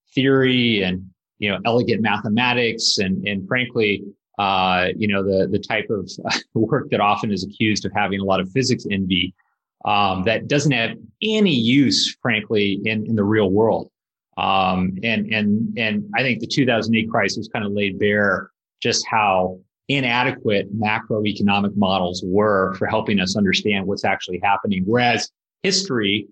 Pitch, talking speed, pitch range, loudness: 105 Hz, 155 wpm, 100-120 Hz, -20 LUFS